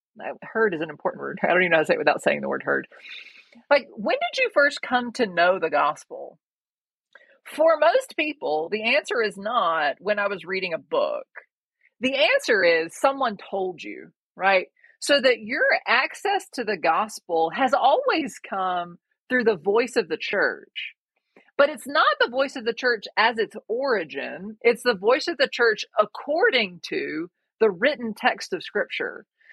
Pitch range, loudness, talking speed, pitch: 210-345 Hz, -23 LUFS, 180 wpm, 255 Hz